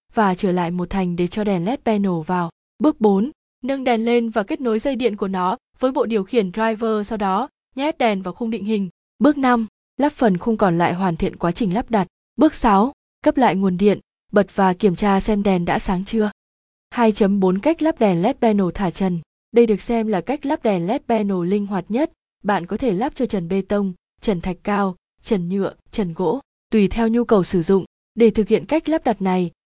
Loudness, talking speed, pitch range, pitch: -20 LUFS, 225 wpm, 190-235 Hz, 215 Hz